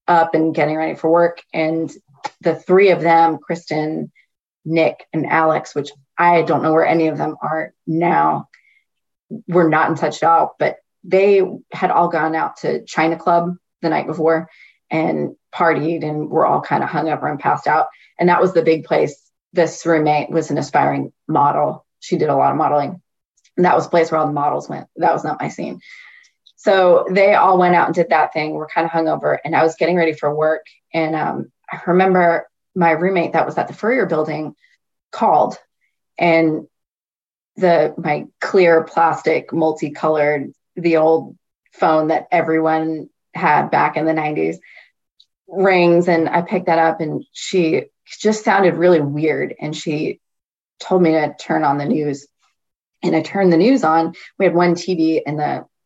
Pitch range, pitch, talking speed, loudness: 155-175 Hz, 165 Hz, 180 wpm, -17 LUFS